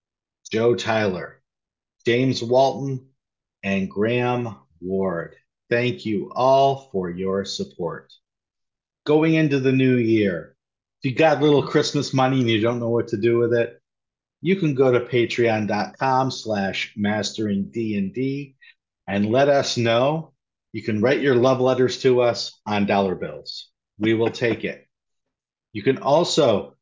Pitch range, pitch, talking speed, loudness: 105-135 Hz, 120 Hz, 140 wpm, -21 LUFS